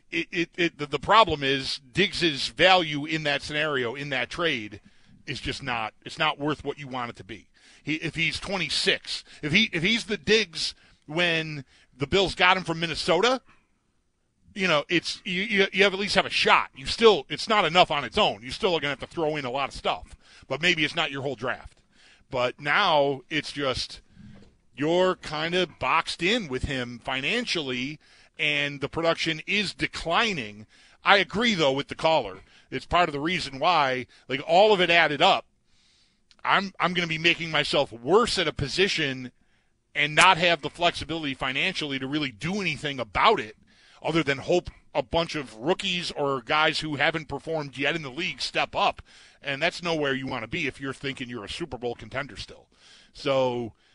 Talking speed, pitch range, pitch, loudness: 195 wpm, 135-175 Hz, 150 Hz, -25 LUFS